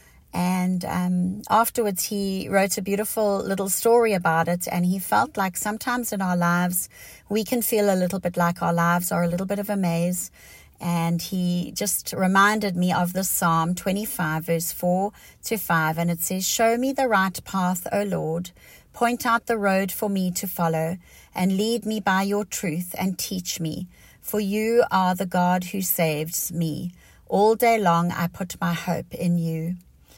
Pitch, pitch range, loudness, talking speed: 185 Hz, 170-205 Hz, -23 LUFS, 185 wpm